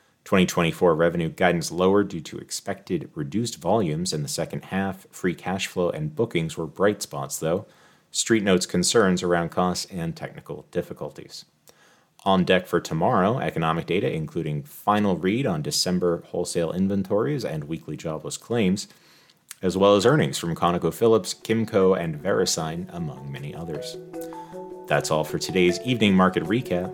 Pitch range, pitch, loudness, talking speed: 85-115 Hz, 95 Hz, -24 LUFS, 145 wpm